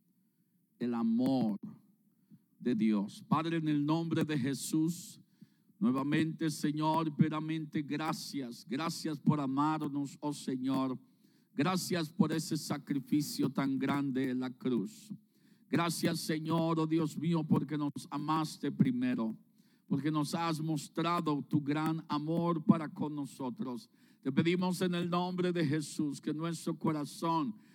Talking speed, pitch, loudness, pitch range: 125 wpm, 160 Hz, -34 LUFS, 150-185 Hz